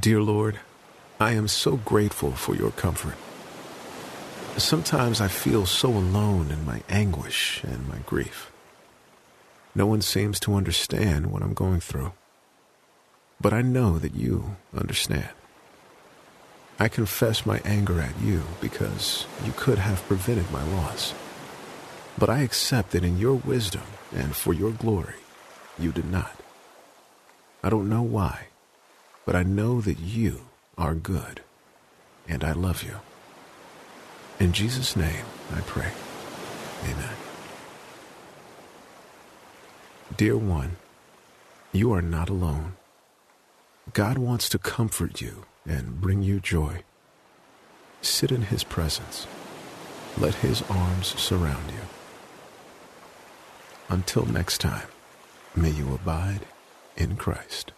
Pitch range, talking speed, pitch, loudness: 85-110 Hz, 120 wpm, 100 Hz, -26 LUFS